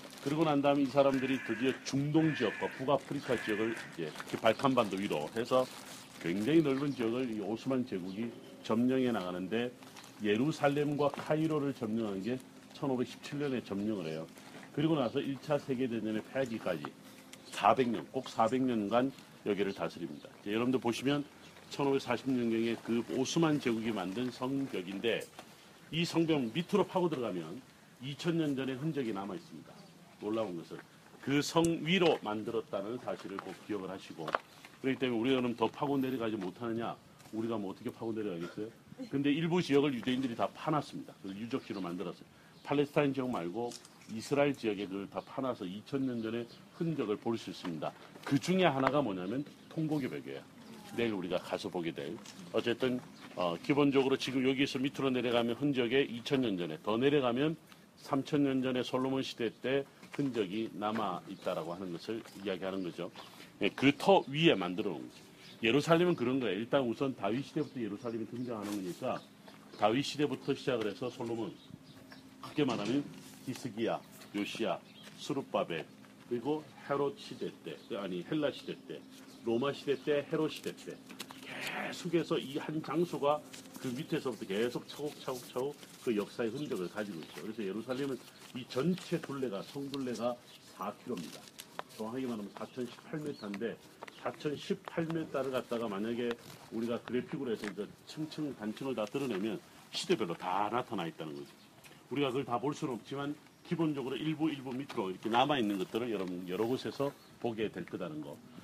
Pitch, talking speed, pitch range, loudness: 130 Hz, 340 characters per minute, 110-145 Hz, -35 LUFS